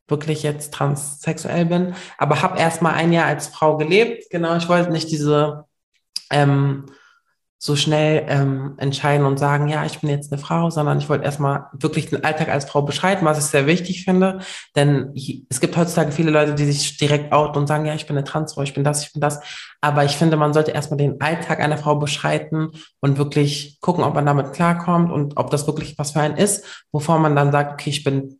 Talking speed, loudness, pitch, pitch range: 215 wpm, -19 LUFS, 150 Hz, 145-160 Hz